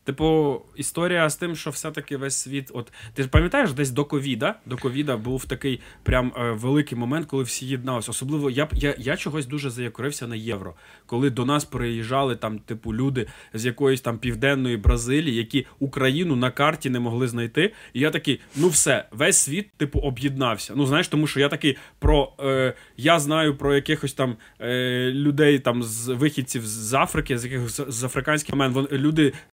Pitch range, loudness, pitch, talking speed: 125-145 Hz, -23 LUFS, 135 Hz, 185 wpm